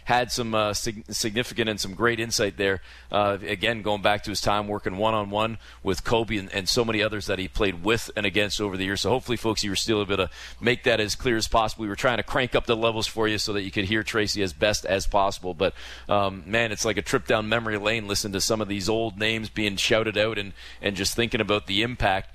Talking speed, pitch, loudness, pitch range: 265 wpm, 105 Hz, -25 LUFS, 100-110 Hz